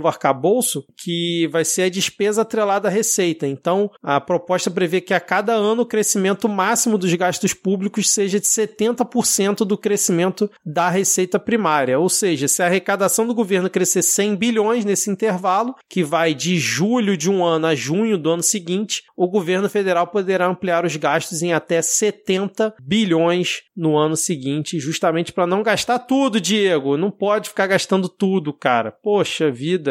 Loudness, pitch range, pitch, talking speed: -19 LUFS, 170-210 Hz, 190 Hz, 165 wpm